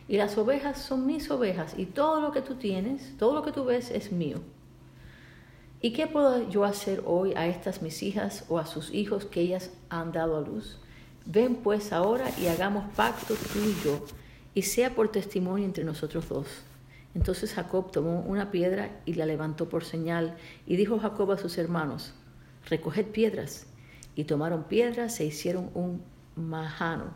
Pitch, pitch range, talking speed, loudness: 185 Hz, 165-215 Hz, 175 wpm, -30 LUFS